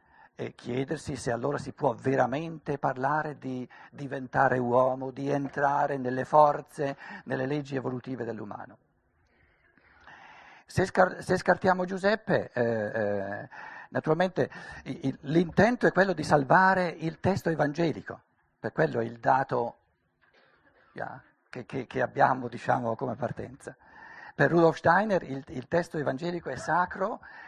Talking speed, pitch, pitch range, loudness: 130 wpm, 140 Hz, 130-170 Hz, -28 LUFS